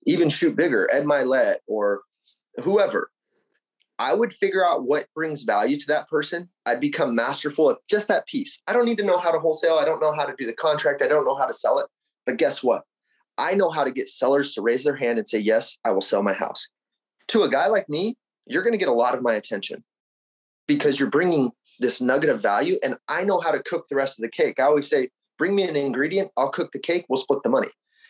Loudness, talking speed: -23 LUFS, 245 wpm